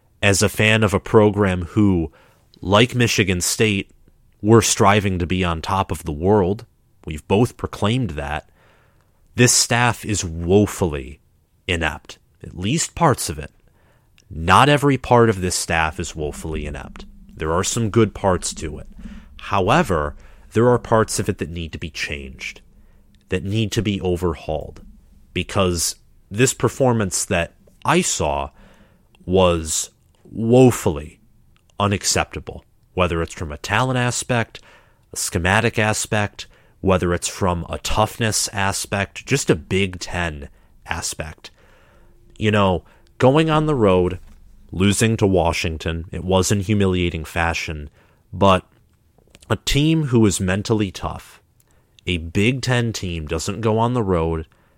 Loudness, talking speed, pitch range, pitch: -19 LUFS, 135 wpm, 85-110 Hz, 95 Hz